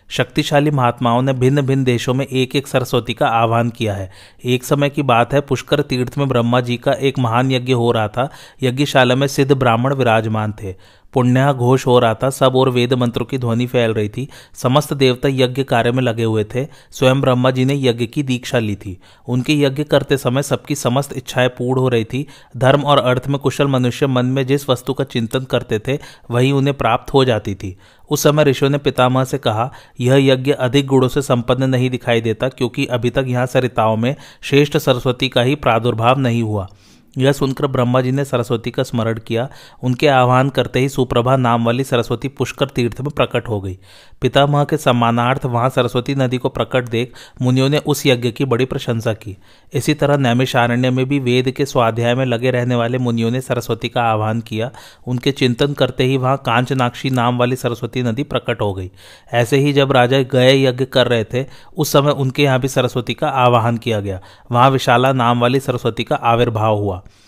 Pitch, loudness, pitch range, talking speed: 125 Hz, -16 LUFS, 120-135 Hz, 200 wpm